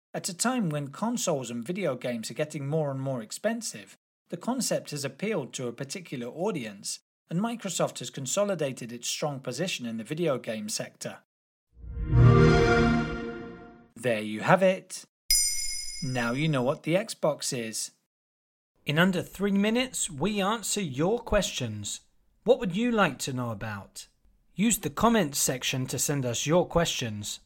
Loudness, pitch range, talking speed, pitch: -28 LUFS, 120-195 Hz, 150 wpm, 150 Hz